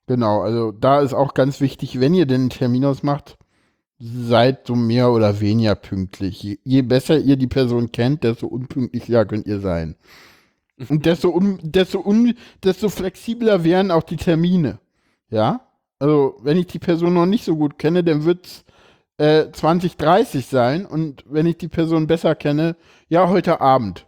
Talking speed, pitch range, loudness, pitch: 175 wpm, 120-170 Hz, -18 LUFS, 145 Hz